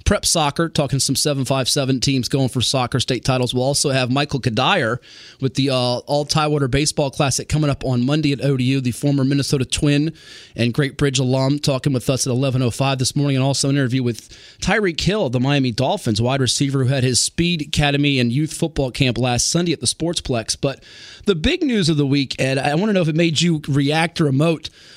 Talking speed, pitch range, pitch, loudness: 210 wpm, 130-150 Hz, 140 Hz, -19 LUFS